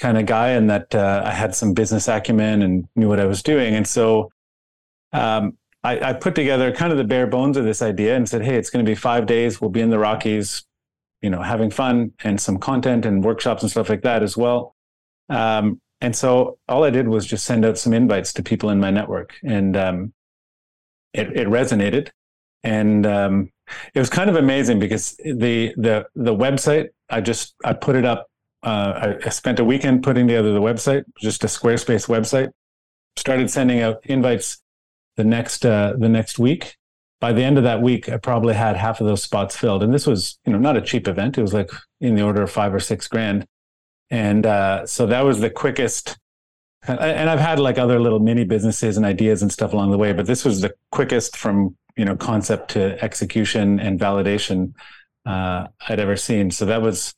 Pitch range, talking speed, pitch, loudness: 100-120 Hz, 210 wpm, 110 Hz, -19 LUFS